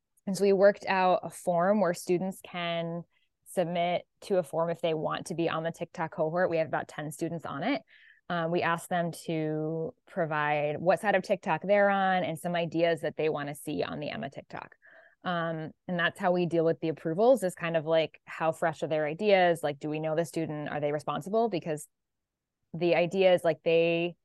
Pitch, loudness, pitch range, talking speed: 165 Hz, -29 LUFS, 155-180 Hz, 215 wpm